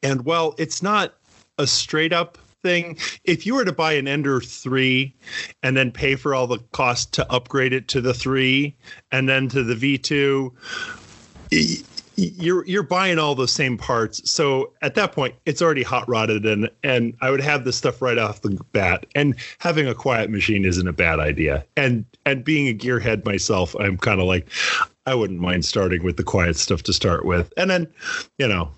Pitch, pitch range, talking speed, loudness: 130 Hz, 110-145 Hz, 195 wpm, -21 LUFS